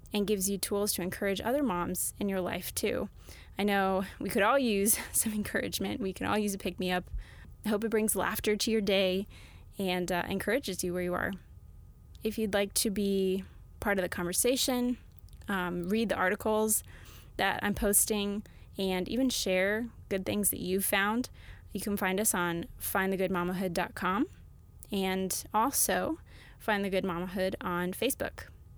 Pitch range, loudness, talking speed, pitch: 185-215 Hz, -31 LUFS, 165 wpm, 195 Hz